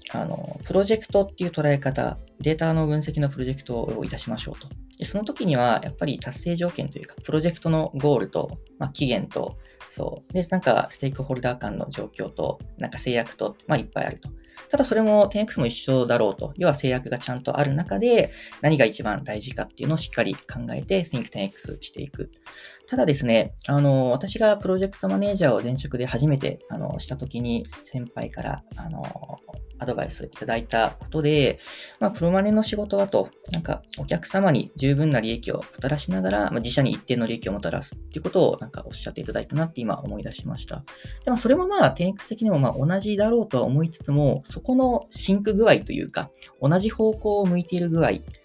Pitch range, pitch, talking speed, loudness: 130-195 Hz, 150 Hz, 425 characters per minute, -24 LUFS